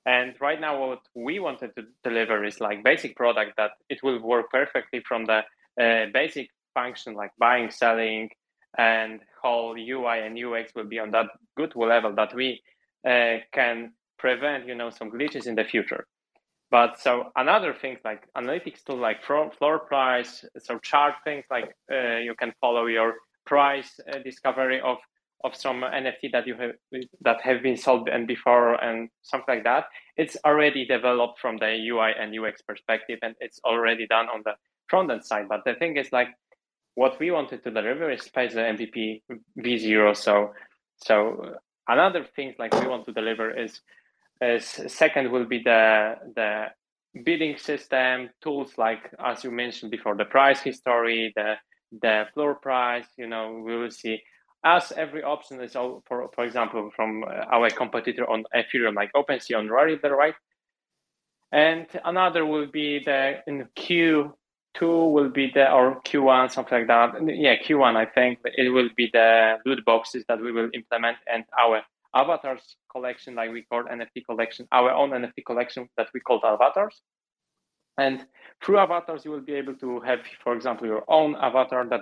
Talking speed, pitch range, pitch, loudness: 175 wpm, 115-135 Hz, 125 Hz, -24 LUFS